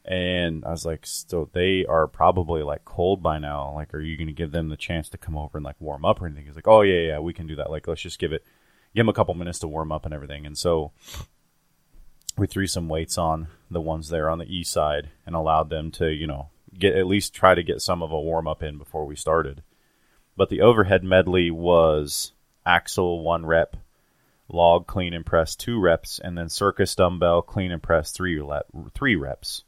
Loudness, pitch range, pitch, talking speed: -23 LUFS, 80-90 Hz, 80 Hz, 225 wpm